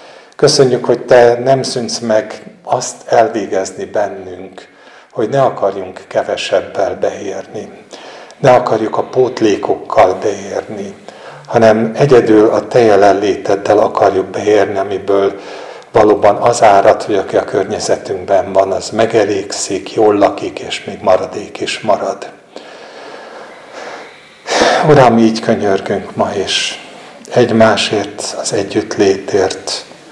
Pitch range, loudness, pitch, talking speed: 110-120 Hz, -12 LUFS, 115 Hz, 105 wpm